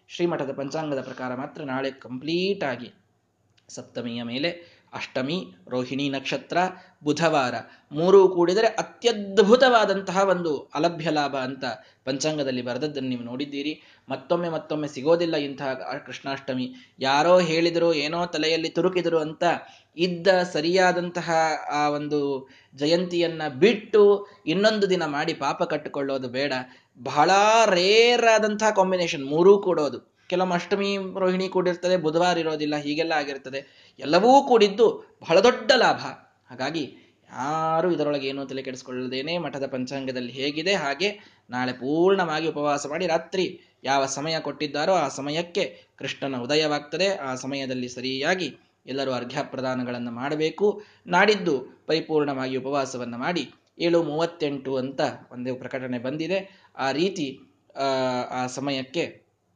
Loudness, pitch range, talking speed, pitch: -24 LUFS, 135-180 Hz, 105 wpm, 155 Hz